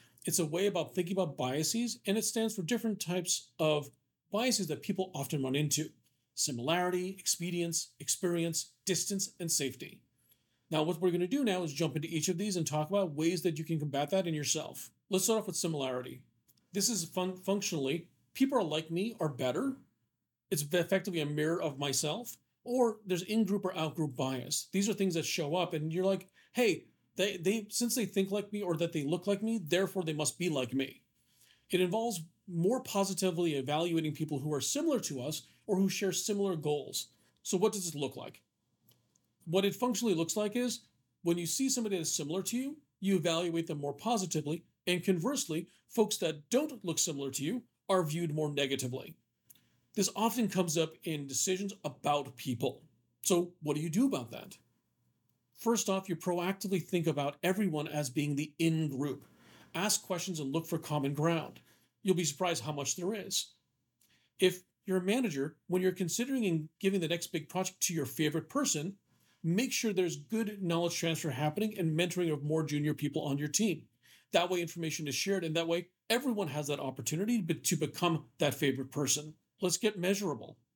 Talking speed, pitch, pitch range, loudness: 190 wpm, 175 Hz, 155-195 Hz, -33 LUFS